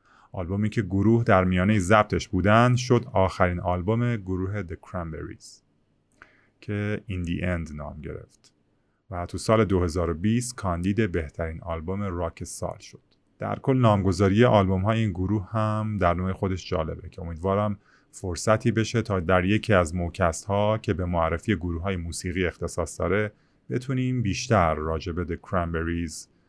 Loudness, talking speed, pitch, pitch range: -25 LUFS, 145 wpm, 95 Hz, 85-110 Hz